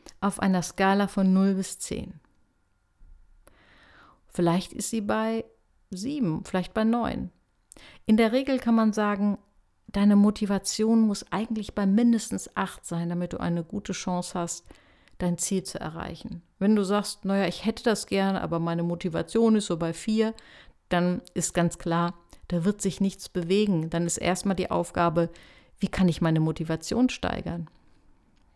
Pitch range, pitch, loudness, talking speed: 175-215 Hz, 195 Hz, -26 LUFS, 155 wpm